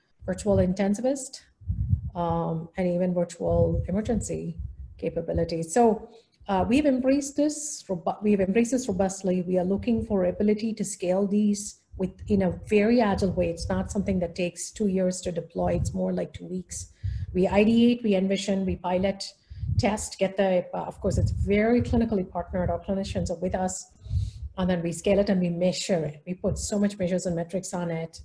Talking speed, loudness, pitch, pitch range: 180 wpm, -26 LUFS, 185 Hz, 170-205 Hz